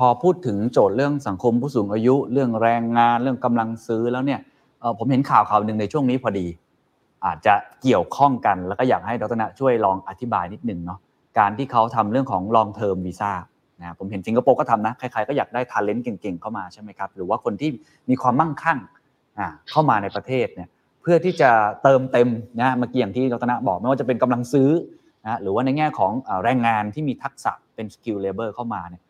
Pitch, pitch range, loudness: 120 Hz, 105-135 Hz, -21 LUFS